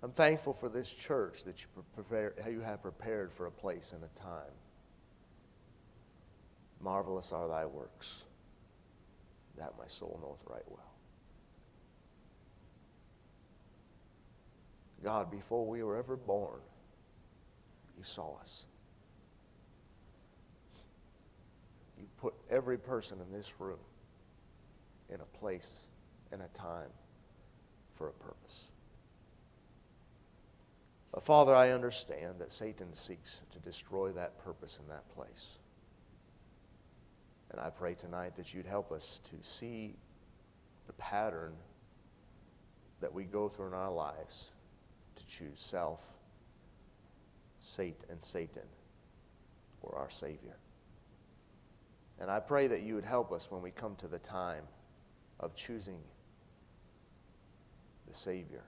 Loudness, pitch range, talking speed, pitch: -39 LUFS, 90-115 Hz, 110 wpm, 100 Hz